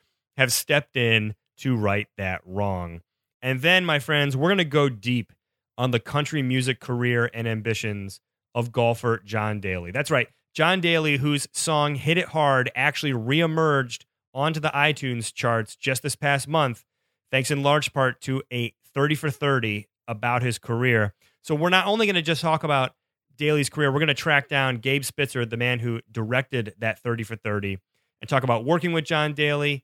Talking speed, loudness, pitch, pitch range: 185 wpm, -23 LUFS, 130 Hz, 115-145 Hz